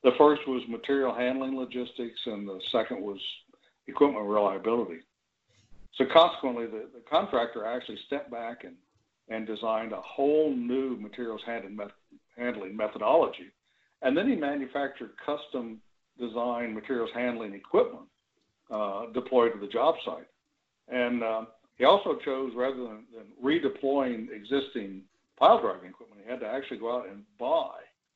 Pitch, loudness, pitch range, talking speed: 120 Hz, -29 LUFS, 110-135 Hz, 145 wpm